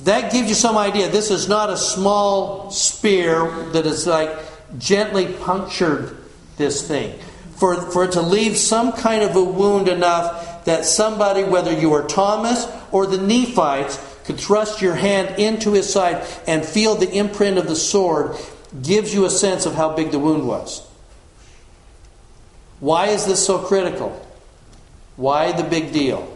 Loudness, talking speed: -18 LUFS, 160 wpm